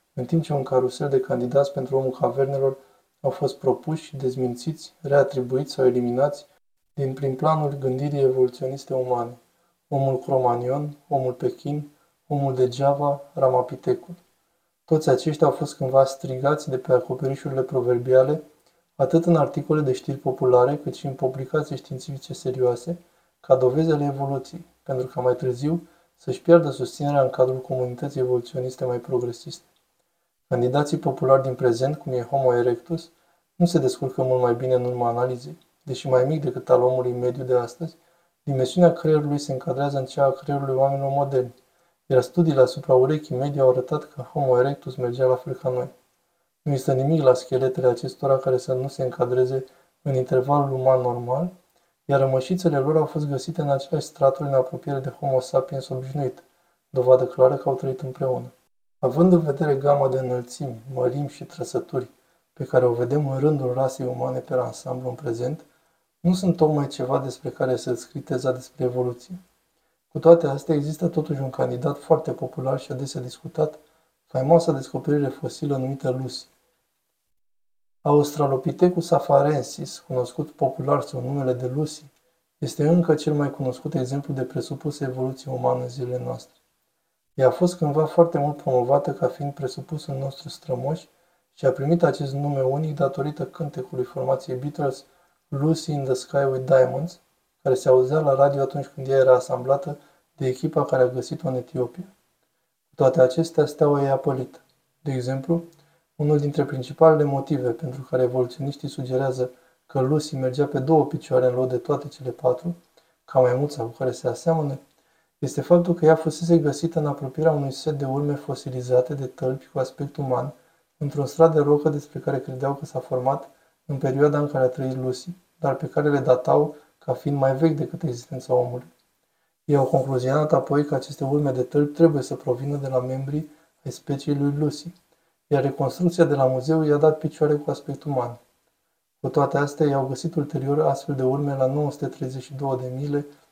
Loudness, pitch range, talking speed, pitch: -23 LUFS, 130-160 Hz, 165 wpm, 140 Hz